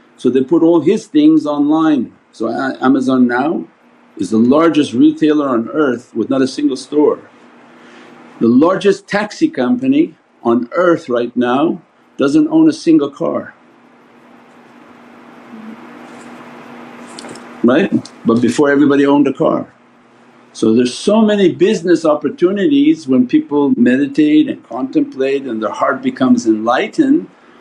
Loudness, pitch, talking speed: -13 LUFS, 185 Hz, 125 wpm